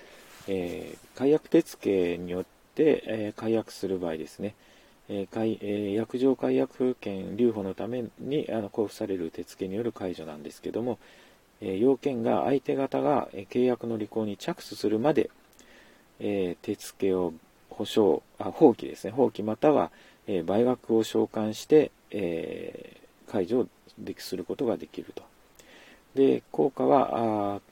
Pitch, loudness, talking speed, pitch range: 105 Hz, -28 LUFS, 270 characters per minute, 95-120 Hz